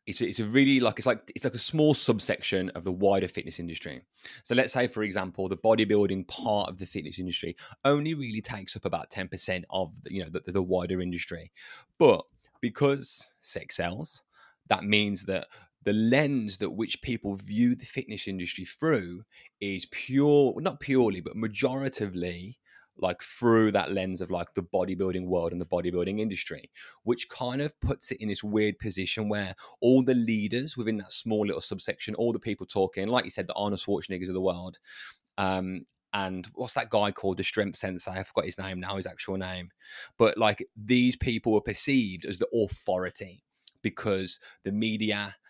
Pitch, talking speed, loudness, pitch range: 105 Hz, 185 wpm, -29 LUFS, 95-120 Hz